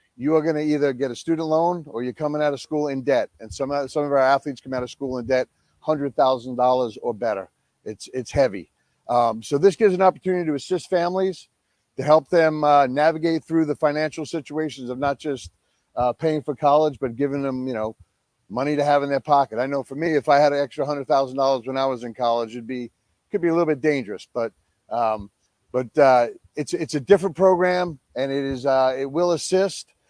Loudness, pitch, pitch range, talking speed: -22 LUFS, 140 Hz, 125-155 Hz, 230 wpm